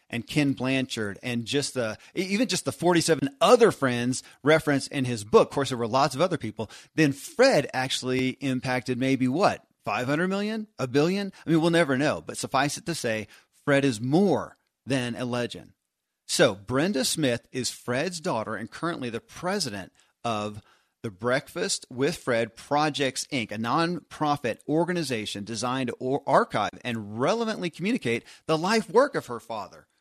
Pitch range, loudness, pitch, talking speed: 120-160 Hz, -26 LUFS, 135 Hz, 165 wpm